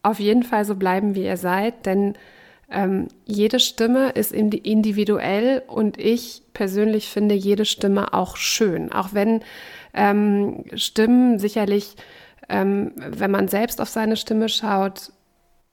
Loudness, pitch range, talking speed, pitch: -21 LUFS, 200-230 Hz, 135 wpm, 210 Hz